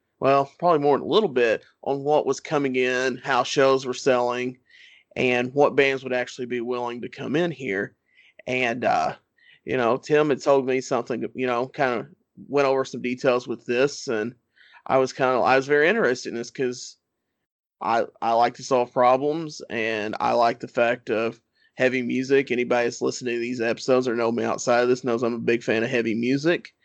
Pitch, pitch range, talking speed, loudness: 125 Hz, 120-135 Hz, 205 wpm, -23 LUFS